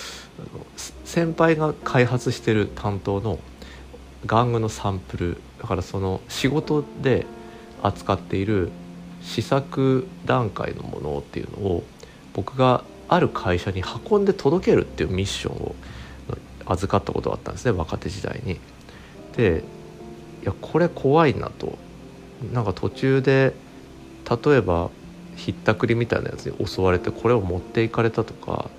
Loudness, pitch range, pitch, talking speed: -23 LUFS, 90-125 Hz, 110 Hz, 275 characters per minute